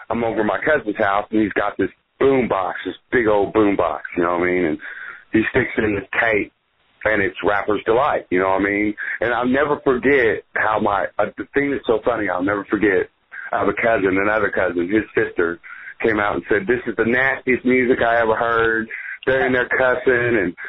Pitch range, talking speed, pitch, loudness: 105-130 Hz, 225 wpm, 115 Hz, -19 LUFS